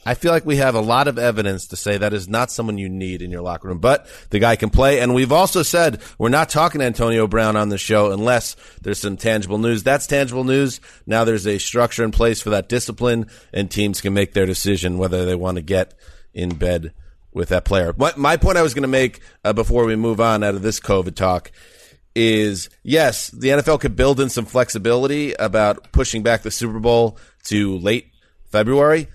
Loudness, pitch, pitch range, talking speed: -18 LUFS, 110 Hz, 100-125 Hz, 220 wpm